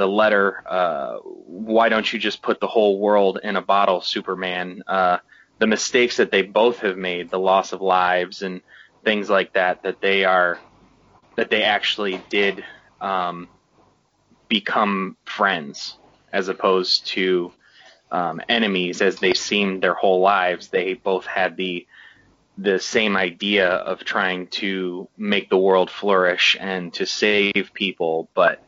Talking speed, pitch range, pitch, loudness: 150 wpm, 90-100 Hz, 95 Hz, -20 LUFS